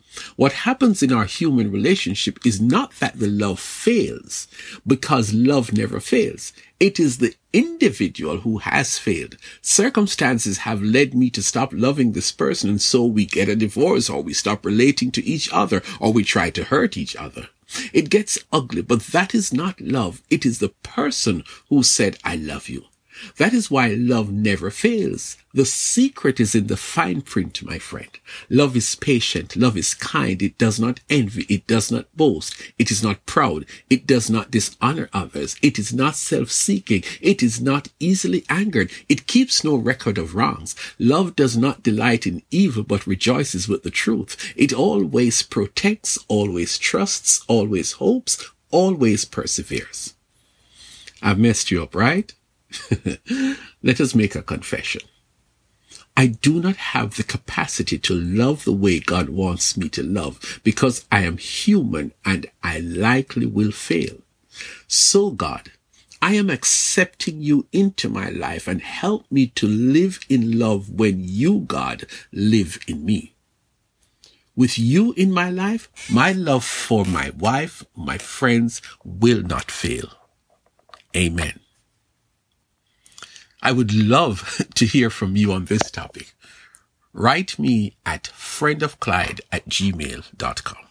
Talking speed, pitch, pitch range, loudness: 150 wpm, 120 Hz, 105-155 Hz, -20 LUFS